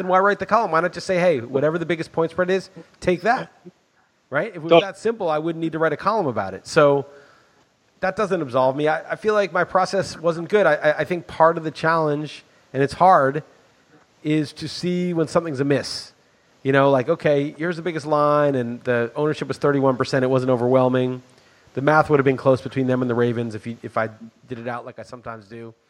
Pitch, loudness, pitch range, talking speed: 150 Hz, -21 LUFS, 130-175 Hz, 230 wpm